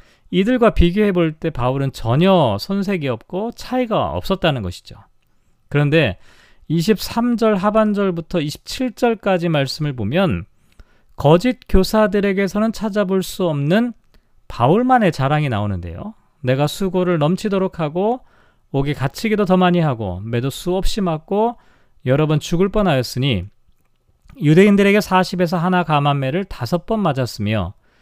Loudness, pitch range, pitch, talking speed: -18 LUFS, 135-200 Hz, 175 Hz, 285 characters per minute